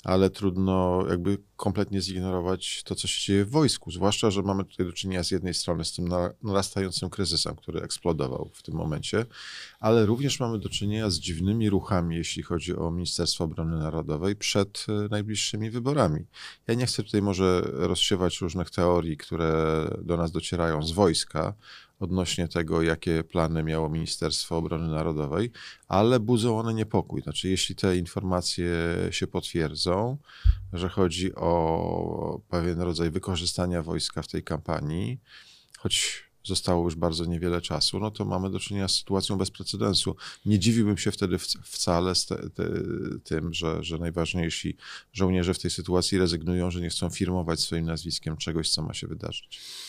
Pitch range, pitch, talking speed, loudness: 85-100 Hz, 90 Hz, 160 wpm, -27 LUFS